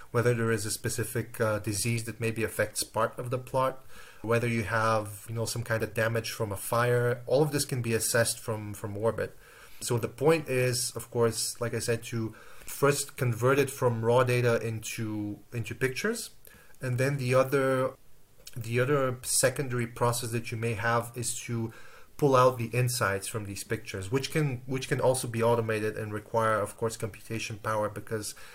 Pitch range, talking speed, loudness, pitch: 110-125 Hz, 185 wpm, -29 LUFS, 115 Hz